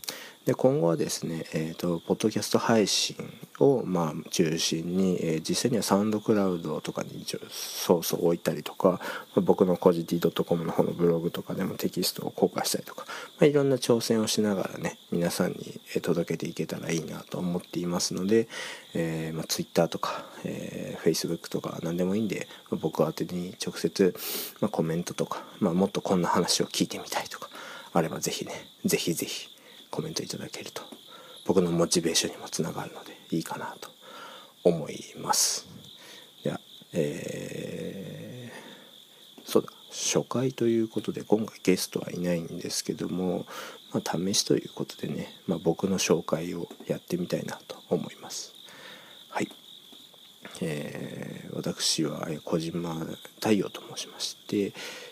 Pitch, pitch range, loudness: 90 Hz, 85-110 Hz, -29 LUFS